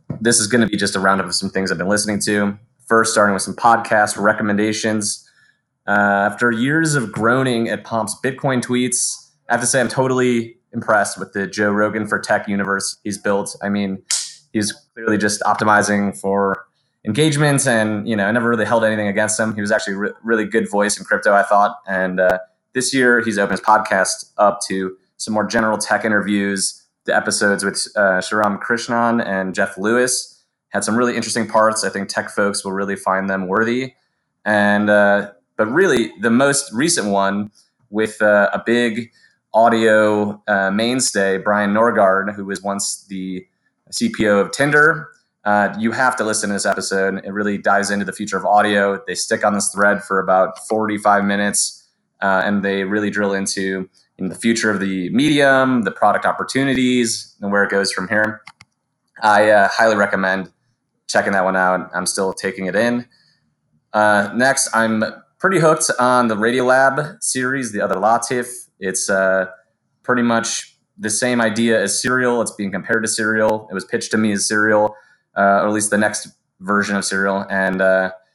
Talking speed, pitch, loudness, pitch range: 185 wpm, 105 Hz, -17 LUFS, 100-115 Hz